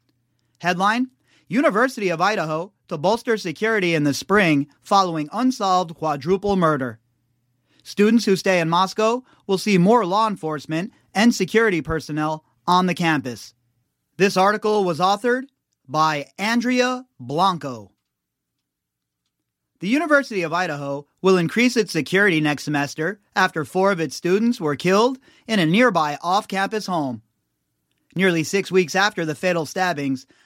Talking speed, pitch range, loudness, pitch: 130 wpm, 145-205 Hz, -20 LUFS, 180 Hz